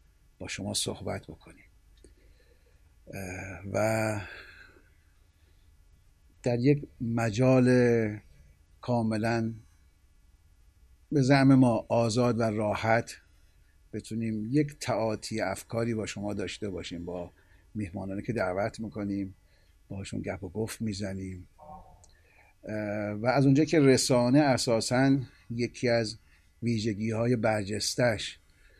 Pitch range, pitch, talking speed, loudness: 85-115 Hz, 105 Hz, 95 wpm, -28 LUFS